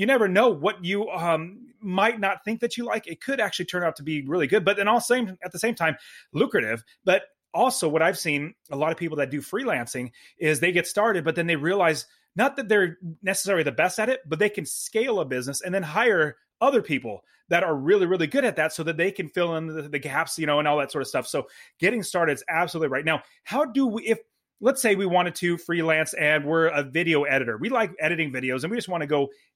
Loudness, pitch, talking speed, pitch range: -24 LUFS, 175 Hz, 255 wpm, 155-215 Hz